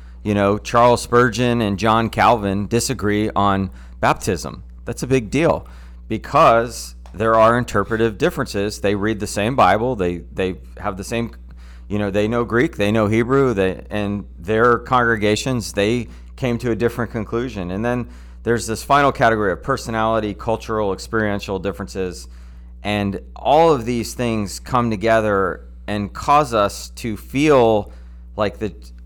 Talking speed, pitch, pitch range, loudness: 150 wpm, 105 Hz, 95-115 Hz, -19 LUFS